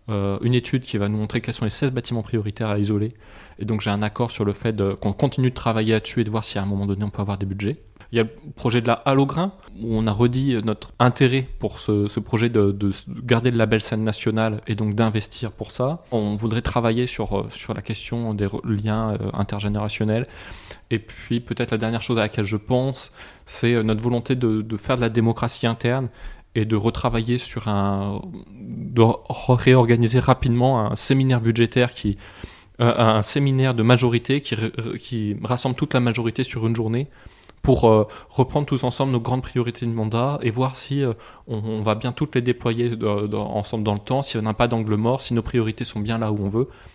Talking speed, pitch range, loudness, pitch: 215 wpm, 105-125 Hz, -22 LUFS, 115 Hz